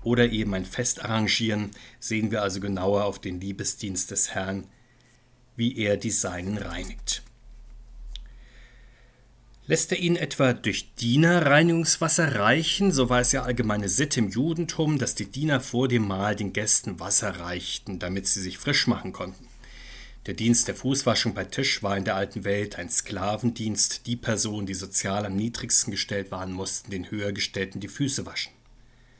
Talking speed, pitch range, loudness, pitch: 160 wpm, 100-125 Hz, -22 LUFS, 110 Hz